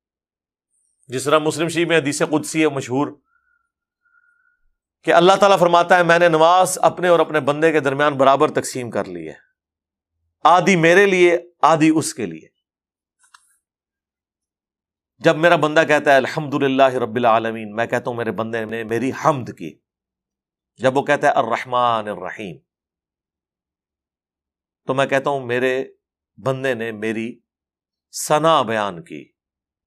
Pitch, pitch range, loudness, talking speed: 135 Hz, 115-165 Hz, -17 LUFS, 140 wpm